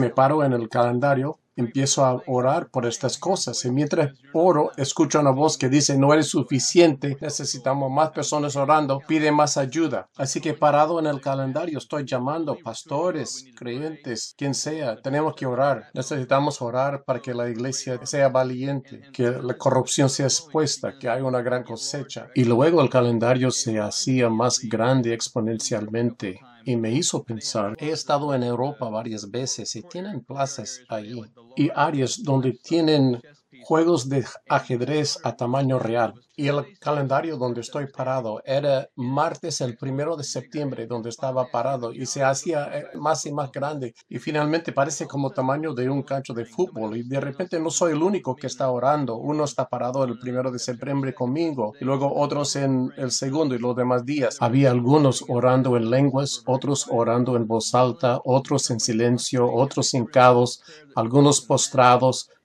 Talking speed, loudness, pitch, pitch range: 165 wpm, -23 LUFS, 135 Hz, 125-145 Hz